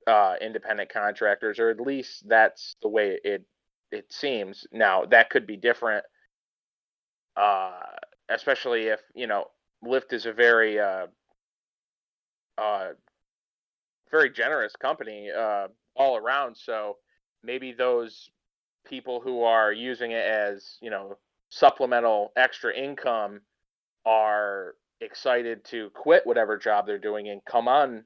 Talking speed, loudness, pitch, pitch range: 125 wpm, -25 LUFS, 115 Hz, 105-135 Hz